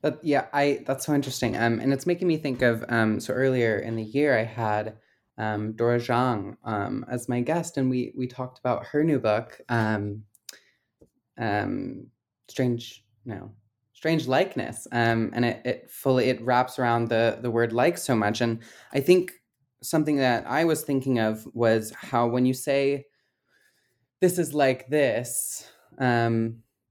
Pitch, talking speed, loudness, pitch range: 125 Hz, 165 wpm, -25 LUFS, 115-135 Hz